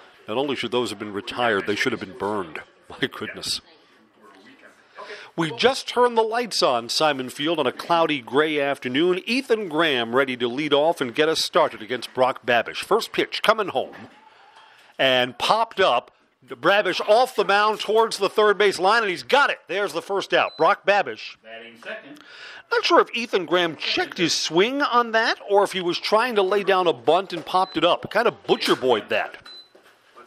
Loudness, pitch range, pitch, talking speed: -21 LUFS, 150-225 Hz, 190 Hz, 190 wpm